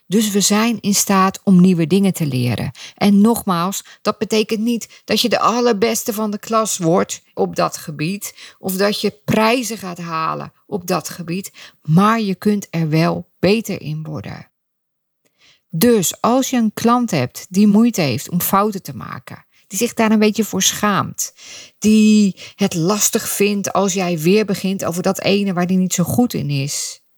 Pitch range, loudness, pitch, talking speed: 175-215 Hz, -17 LUFS, 195 Hz, 180 wpm